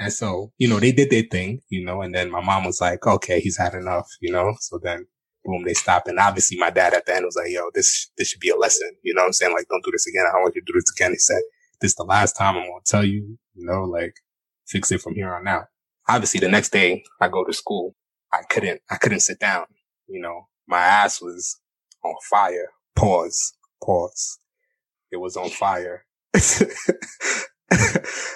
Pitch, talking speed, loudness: 140 Hz, 230 wpm, -20 LUFS